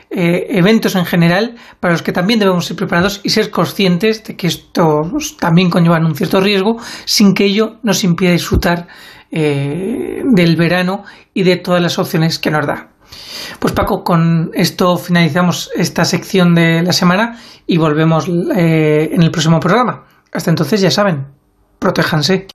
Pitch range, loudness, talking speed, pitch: 165-200 Hz, -13 LUFS, 160 wpm, 180 Hz